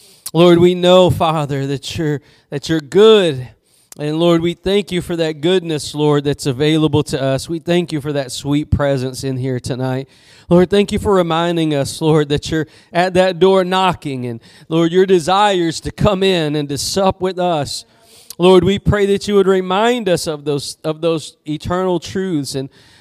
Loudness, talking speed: -15 LUFS, 190 wpm